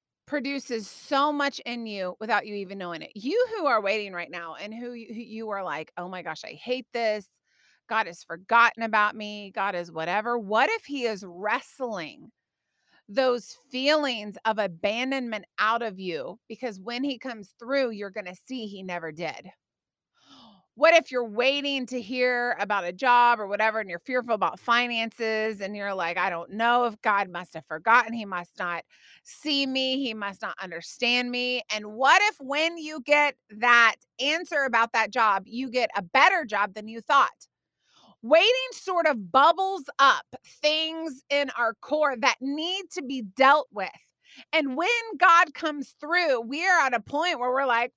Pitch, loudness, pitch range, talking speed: 240 Hz, -25 LUFS, 210-275 Hz, 180 wpm